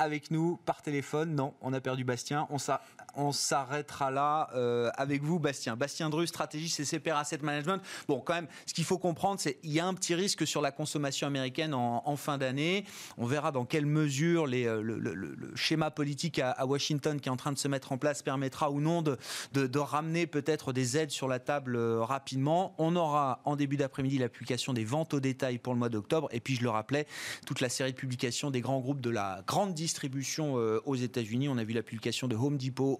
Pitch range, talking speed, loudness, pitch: 130-155 Hz, 230 wpm, -32 LUFS, 145 Hz